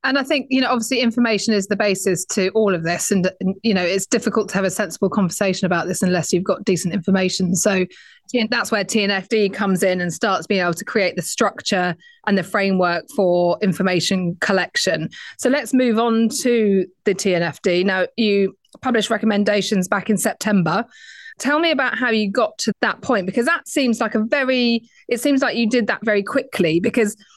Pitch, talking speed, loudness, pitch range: 205 Hz, 200 wpm, -19 LUFS, 190-240 Hz